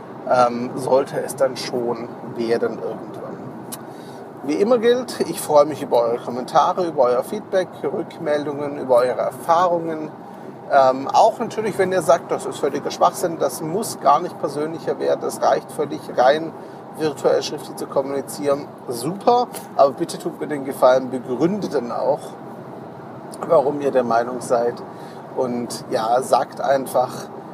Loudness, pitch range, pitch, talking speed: -20 LUFS, 125-170 Hz, 140 Hz, 145 wpm